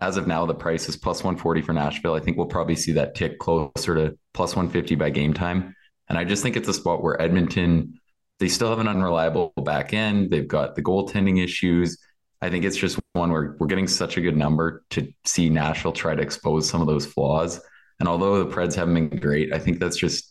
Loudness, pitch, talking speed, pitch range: -23 LUFS, 85 Hz, 230 wpm, 80-90 Hz